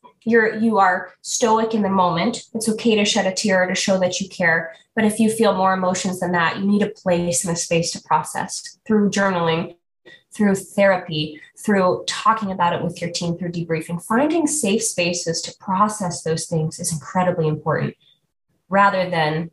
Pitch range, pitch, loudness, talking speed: 170-210 Hz, 185 Hz, -20 LUFS, 185 wpm